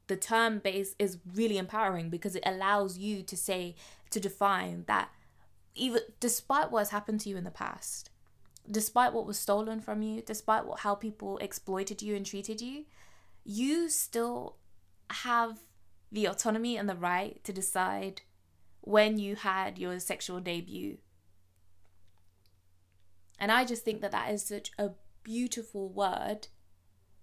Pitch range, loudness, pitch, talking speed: 175-220 Hz, -33 LUFS, 200 Hz, 150 wpm